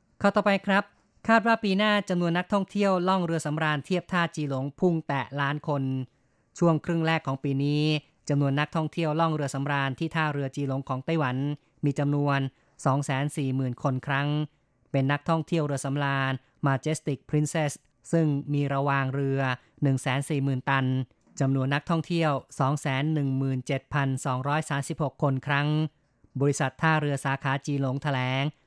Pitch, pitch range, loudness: 145 Hz, 135-160 Hz, -27 LUFS